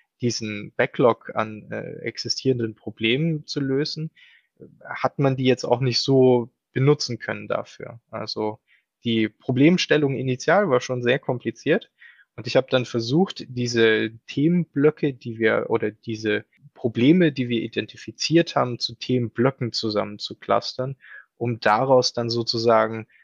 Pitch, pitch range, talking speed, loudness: 120 Hz, 115-135 Hz, 130 wpm, -23 LUFS